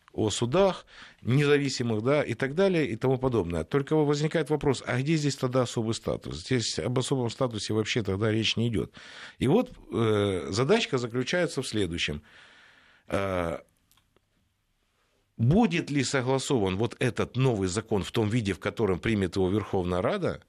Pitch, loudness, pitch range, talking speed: 120 Hz, -27 LUFS, 100-135 Hz, 145 wpm